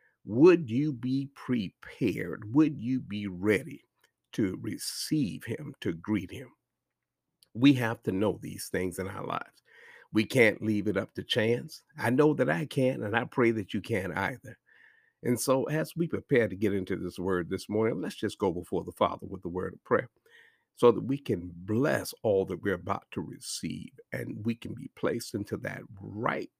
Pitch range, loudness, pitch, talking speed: 100-130 Hz, -30 LUFS, 110 Hz, 190 wpm